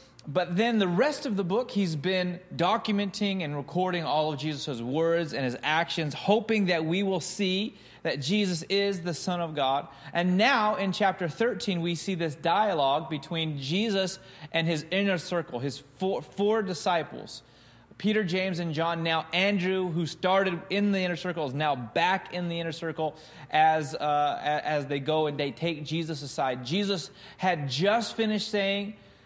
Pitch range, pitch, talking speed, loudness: 155-195 Hz, 175 Hz, 170 wpm, -28 LUFS